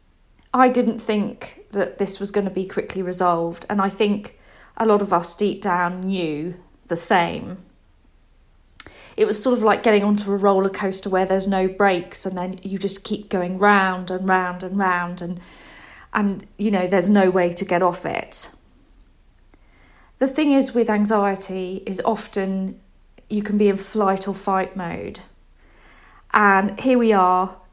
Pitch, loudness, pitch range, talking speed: 195 Hz, -21 LUFS, 185-210 Hz, 170 wpm